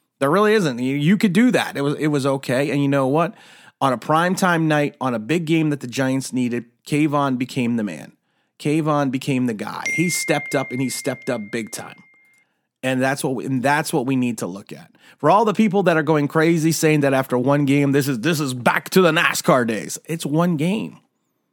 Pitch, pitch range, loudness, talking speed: 145 Hz, 135-165 Hz, -20 LUFS, 230 wpm